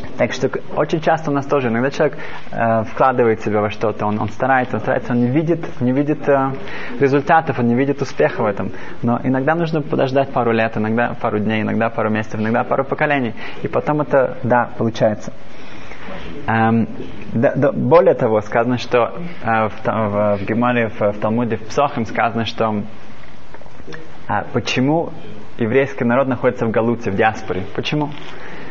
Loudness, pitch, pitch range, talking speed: -18 LUFS, 120 Hz, 110-140 Hz, 170 wpm